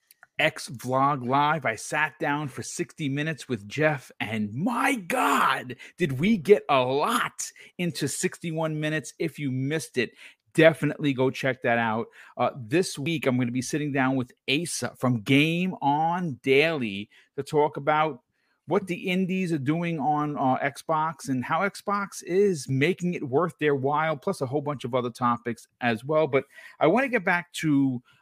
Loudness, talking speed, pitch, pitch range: -26 LUFS, 175 wpm, 150 Hz, 130-165 Hz